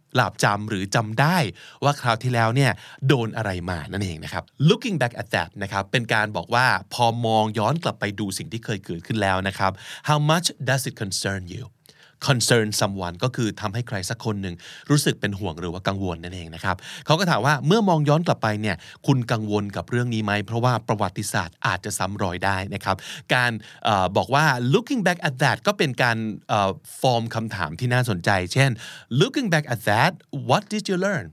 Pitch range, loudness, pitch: 100-140 Hz, -23 LUFS, 115 Hz